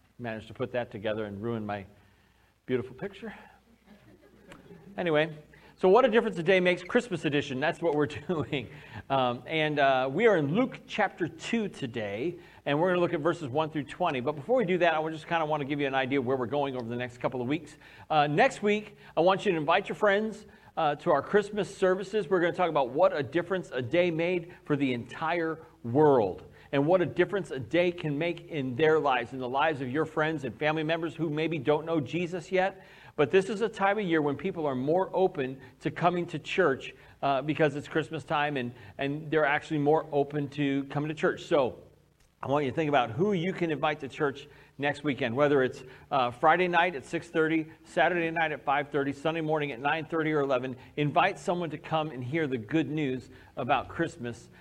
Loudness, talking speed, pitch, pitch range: -29 LUFS, 220 wpm, 155 Hz, 140-175 Hz